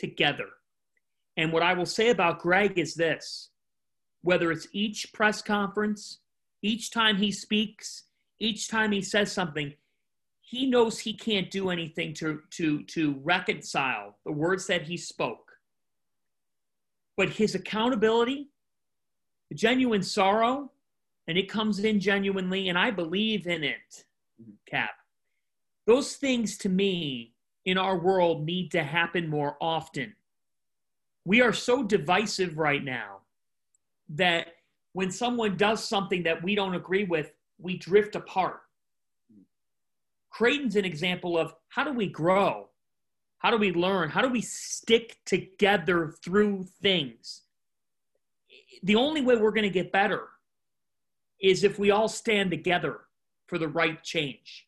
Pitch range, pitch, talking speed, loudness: 170-215 Hz, 190 Hz, 135 wpm, -27 LUFS